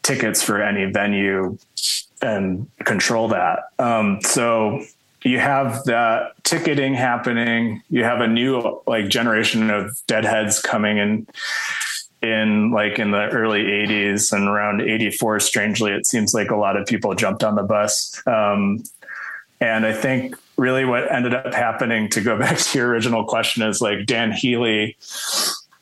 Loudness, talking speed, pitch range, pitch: -19 LUFS, 150 wpm, 105-120 Hz, 110 Hz